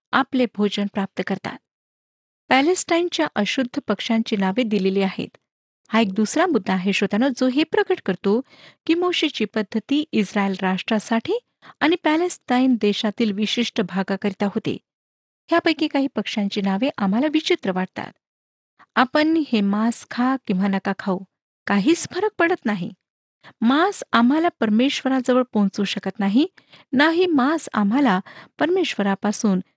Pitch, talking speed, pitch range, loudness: 230 Hz, 120 wpm, 205-305 Hz, -21 LUFS